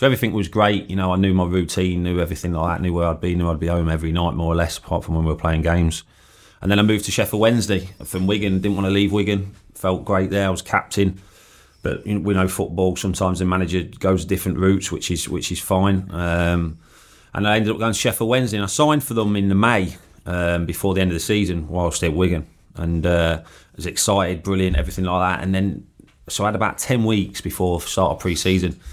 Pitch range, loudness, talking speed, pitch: 85-100 Hz, -20 LUFS, 250 wpm, 95 Hz